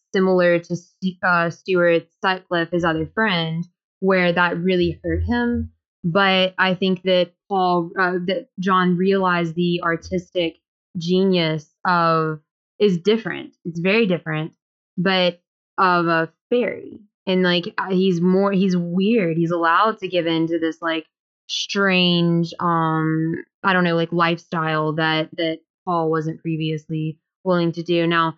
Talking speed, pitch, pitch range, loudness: 135 wpm, 175 Hz, 165-185 Hz, -20 LUFS